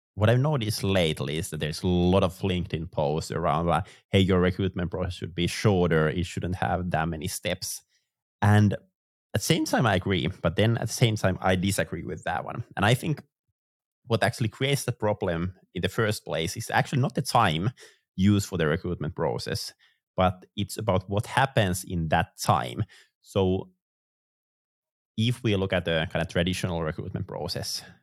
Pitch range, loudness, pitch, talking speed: 90-110 Hz, -27 LUFS, 95 Hz, 185 wpm